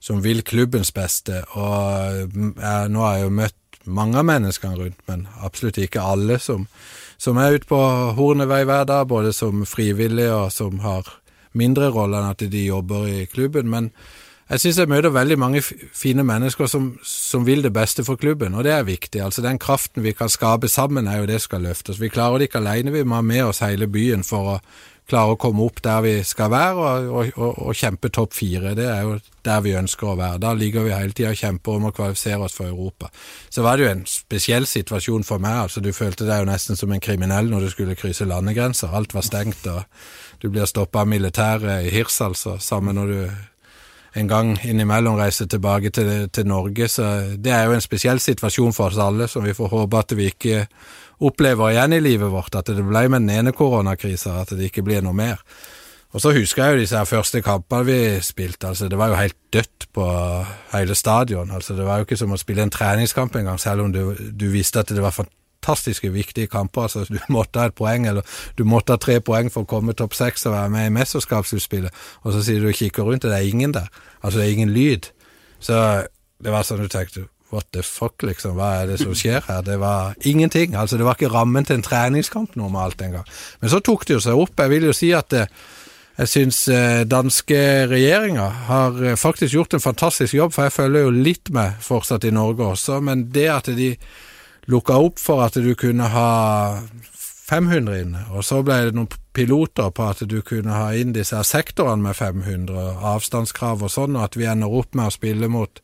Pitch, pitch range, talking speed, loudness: 110 Hz, 100-125 Hz, 220 wpm, -20 LUFS